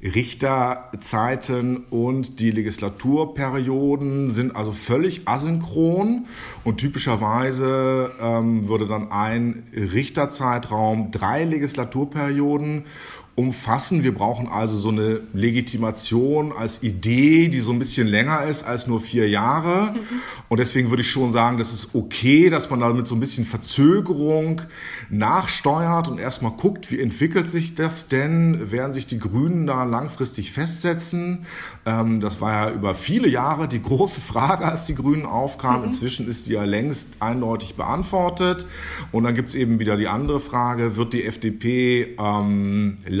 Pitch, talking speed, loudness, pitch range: 125 Hz, 145 wpm, -22 LUFS, 115-145 Hz